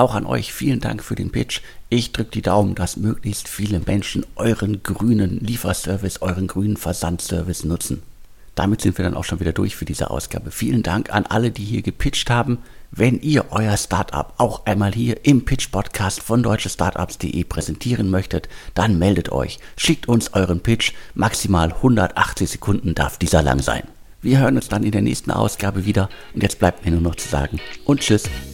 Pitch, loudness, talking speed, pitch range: 100 Hz, -20 LUFS, 185 wpm, 90-115 Hz